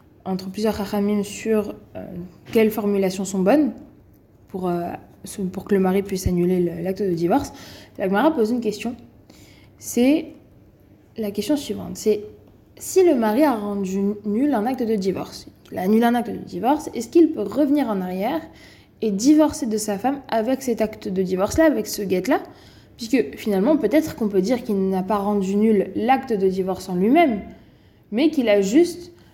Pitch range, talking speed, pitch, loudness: 190-255 Hz, 180 wpm, 210 Hz, -21 LUFS